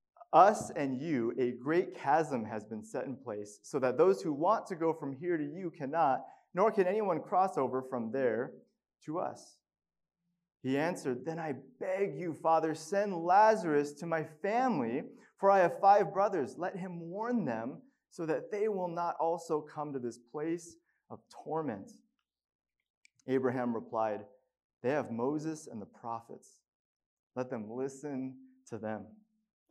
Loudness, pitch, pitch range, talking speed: -33 LUFS, 160 Hz, 130-185 Hz, 160 wpm